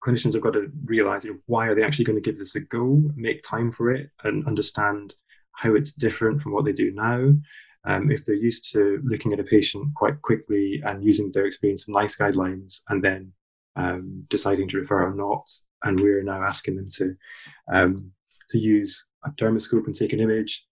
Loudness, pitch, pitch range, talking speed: -23 LUFS, 105 Hz, 100-120 Hz, 210 wpm